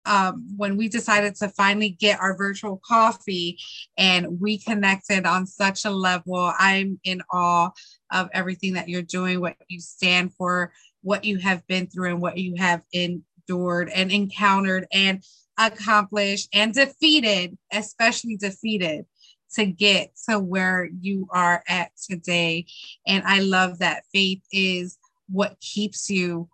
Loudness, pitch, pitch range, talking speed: -22 LUFS, 190 Hz, 180-205 Hz, 145 wpm